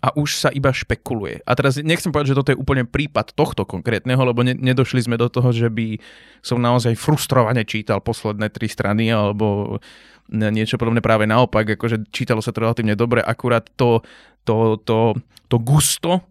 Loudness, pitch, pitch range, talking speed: -19 LUFS, 120 Hz, 110-130 Hz, 175 wpm